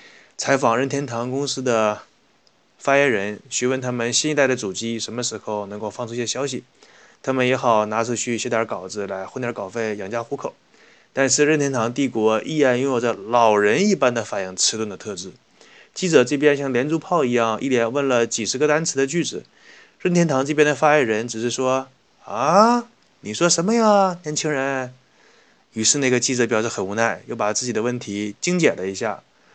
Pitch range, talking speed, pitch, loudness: 115-145 Hz, 290 characters per minute, 125 Hz, -20 LUFS